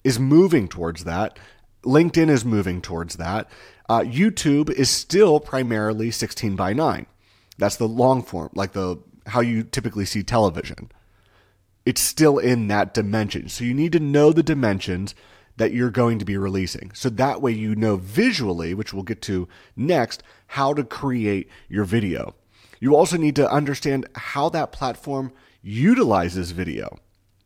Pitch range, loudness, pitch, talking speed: 95-135 Hz, -21 LUFS, 110 Hz, 155 wpm